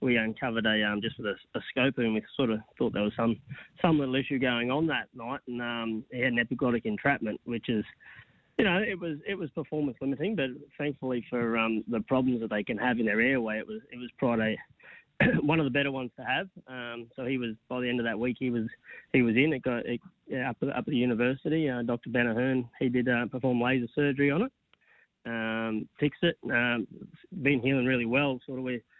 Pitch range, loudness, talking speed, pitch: 115-140 Hz, -29 LUFS, 230 wpm, 125 Hz